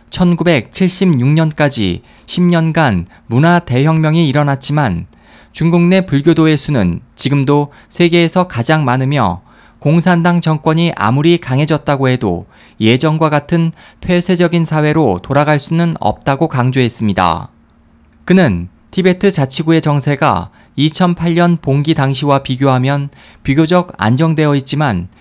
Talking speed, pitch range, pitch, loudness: 265 characters per minute, 125-170 Hz, 150 Hz, -13 LUFS